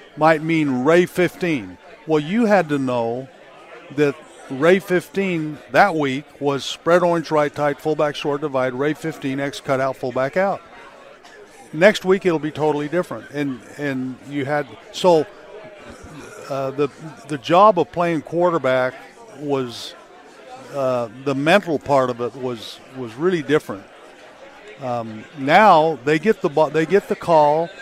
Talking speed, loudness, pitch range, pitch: 145 wpm, -19 LUFS, 135-175 Hz, 150 Hz